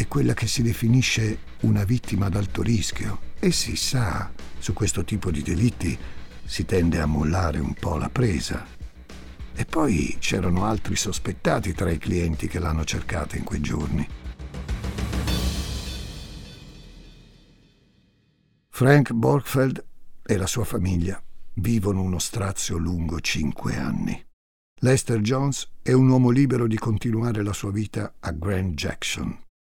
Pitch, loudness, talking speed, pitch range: 100 Hz, -24 LUFS, 135 wpm, 85-115 Hz